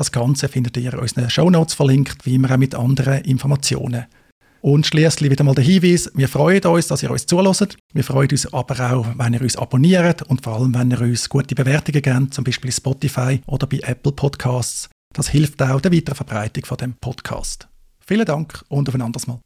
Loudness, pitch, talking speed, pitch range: -18 LUFS, 135 Hz, 210 wpm, 125-145 Hz